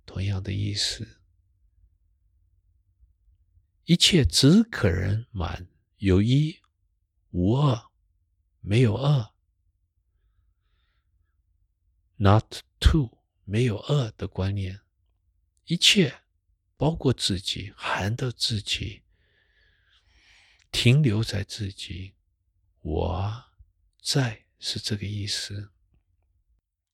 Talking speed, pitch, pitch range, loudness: 115 characters per minute, 95 Hz, 85-105 Hz, -24 LUFS